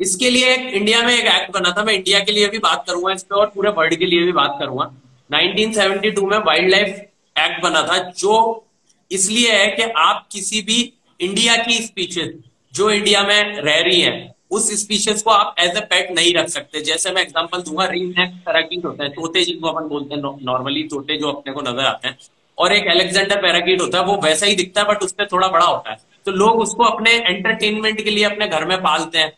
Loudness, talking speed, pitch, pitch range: -16 LUFS, 225 wpm, 190 Hz, 165-210 Hz